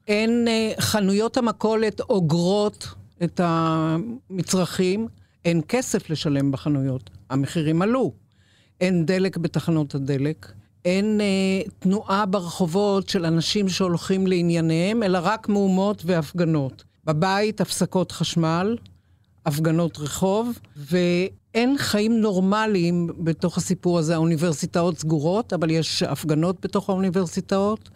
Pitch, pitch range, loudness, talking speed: 180 Hz, 160-200 Hz, -23 LUFS, 100 wpm